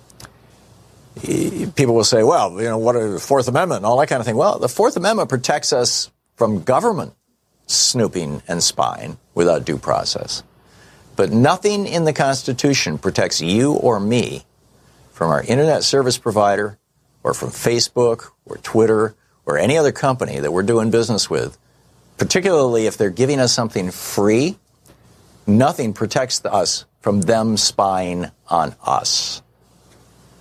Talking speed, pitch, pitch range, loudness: 145 wpm, 115 Hz, 100-125 Hz, -18 LUFS